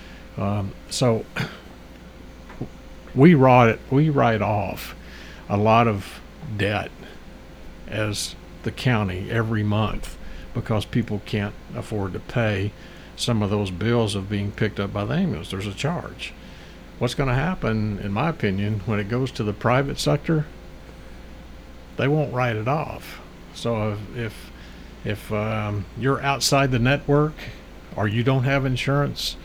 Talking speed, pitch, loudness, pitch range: 140 wpm, 110 Hz, -23 LUFS, 100-130 Hz